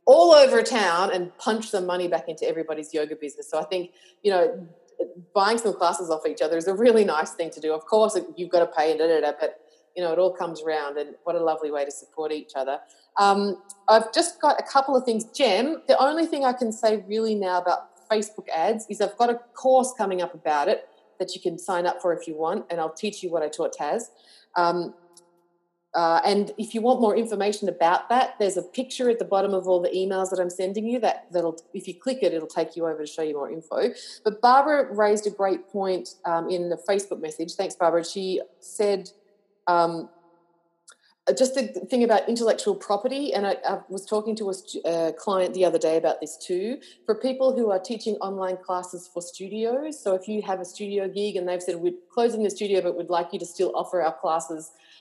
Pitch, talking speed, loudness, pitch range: 185 Hz, 230 wpm, -24 LUFS, 170-215 Hz